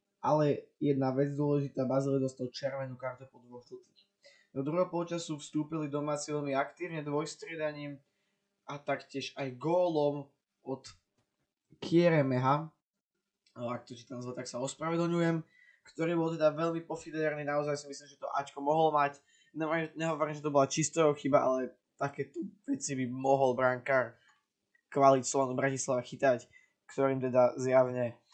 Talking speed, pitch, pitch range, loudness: 135 wpm, 145 Hz, 130-155 Hz, -32 LUFS